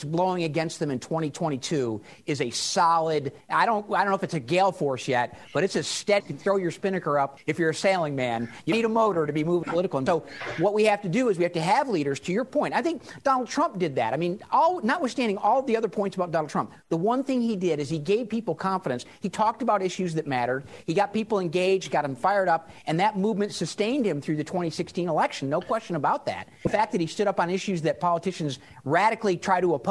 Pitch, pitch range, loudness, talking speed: 180 Hz, 155-210 Hz, -26 LUFS, 255 wpm